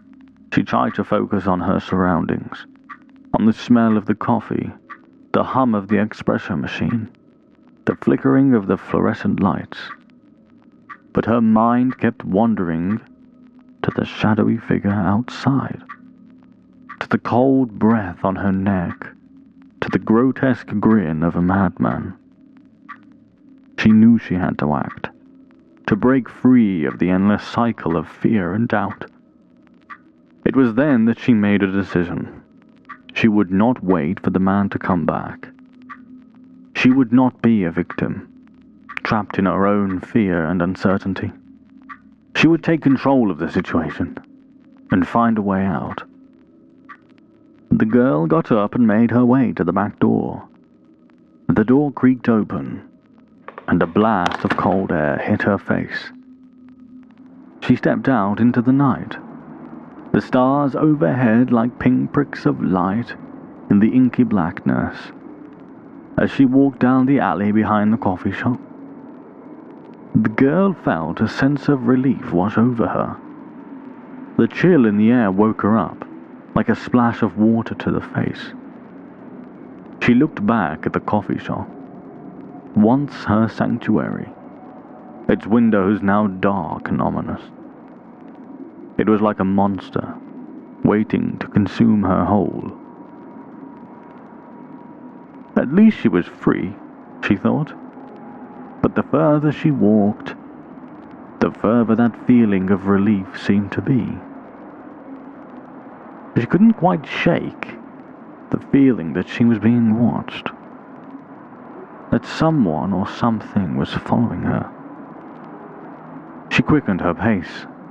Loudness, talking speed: -18 LUFS, 130 wpm